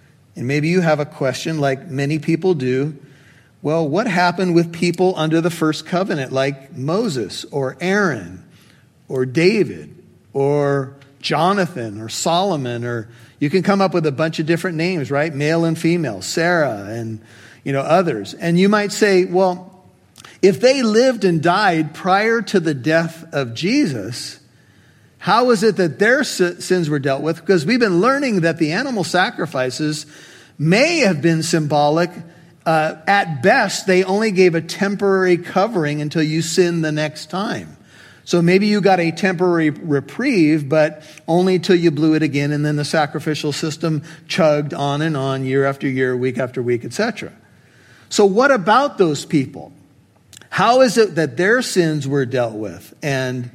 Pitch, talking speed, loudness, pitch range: 160 Hz, 165 wpm, -17 LUFS, 140-185 Hz